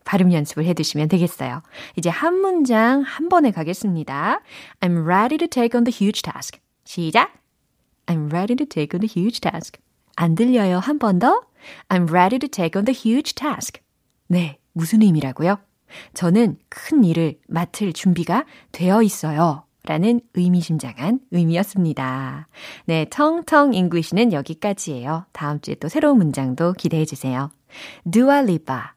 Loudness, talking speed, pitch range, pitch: -20 LUFS, 385 characters per minute, 160-235 Hz, 180 Hz